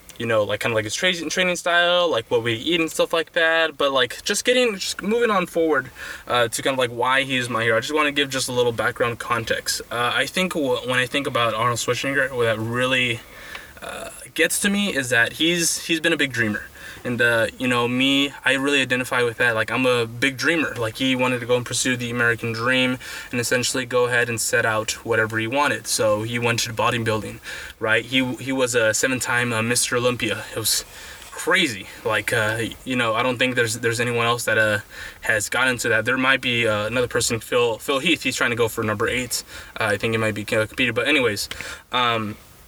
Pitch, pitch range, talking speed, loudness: 125 Hz, 115-155 Hz, 230 wpm, -21 LUFS